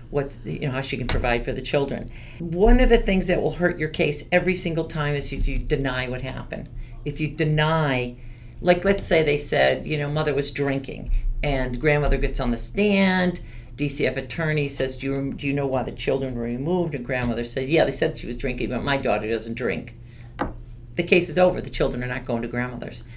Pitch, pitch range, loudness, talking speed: 135 Hz, 120-155 Hz, -23 LUFS, 225 wpm